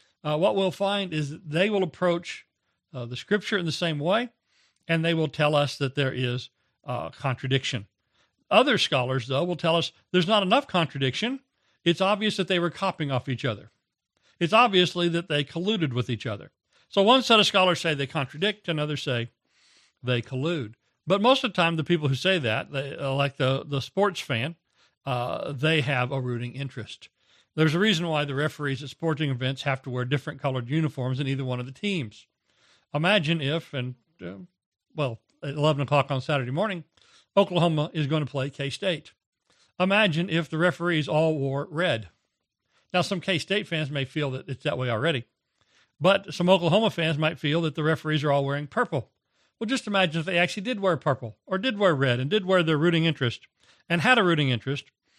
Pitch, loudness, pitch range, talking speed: 155 Hz, -25 LUFS, 135-180 Hz, 195 wpm